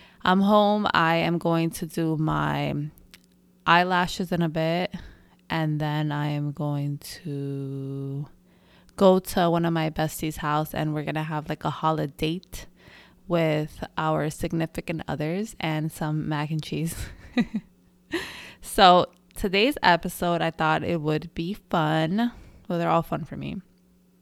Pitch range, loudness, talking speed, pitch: 150-180 Hz, -25 LUFS, 145 wpm, 160 Hz